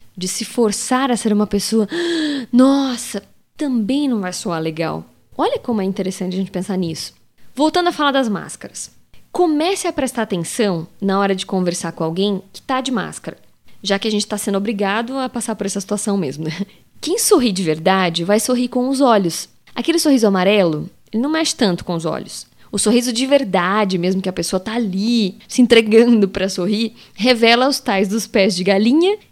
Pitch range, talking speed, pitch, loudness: 190-255 Hz, 190 wpm, 215 Hz, -17 LUFS